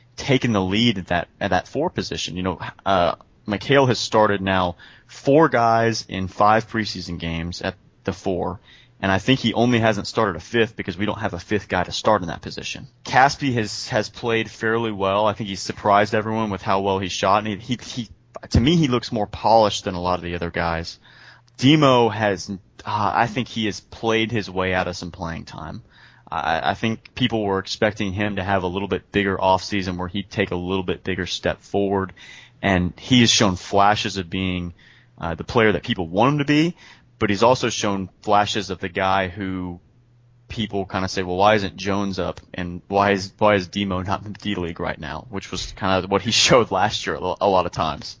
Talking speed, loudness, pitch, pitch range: 220 wpm, -21 LUFS, 100 Hz, 95-115 Hz